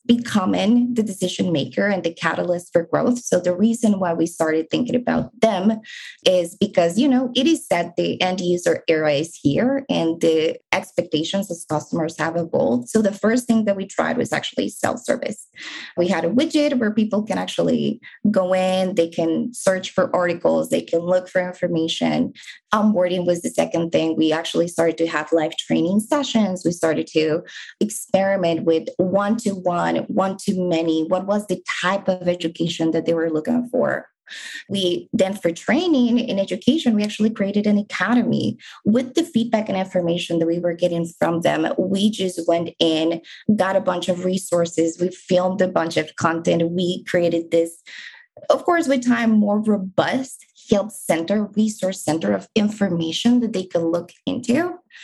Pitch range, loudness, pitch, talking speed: 170-220 Hz, -20 LUFS, 185 Hz, 170 wpm